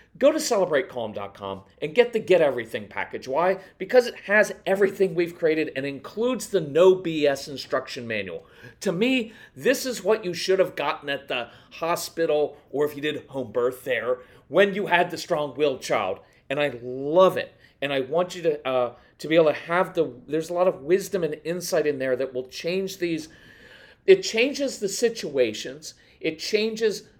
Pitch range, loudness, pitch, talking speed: 140-200 Hz, -24 LUFS, 170 Hz, 185 wpm